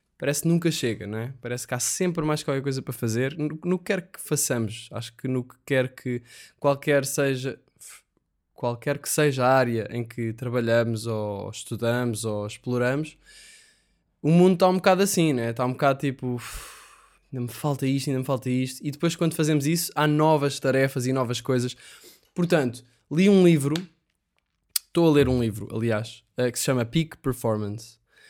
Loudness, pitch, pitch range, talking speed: -25 LUFS, 130 Hz, 120-155 Hz, 180 wpm